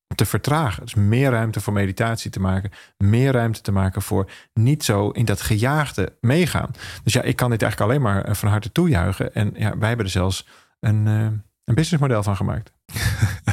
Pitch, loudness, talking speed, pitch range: 110 Hz, -21 LUFS, 185 wpm, 100-125 Hz